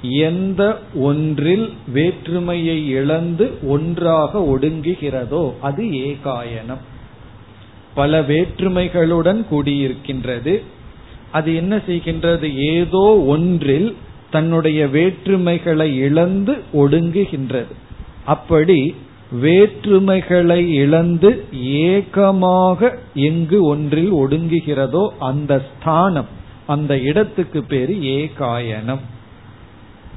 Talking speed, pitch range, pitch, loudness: 65 wpm, 135-175 Hz, 155 Hz, -16 LUFS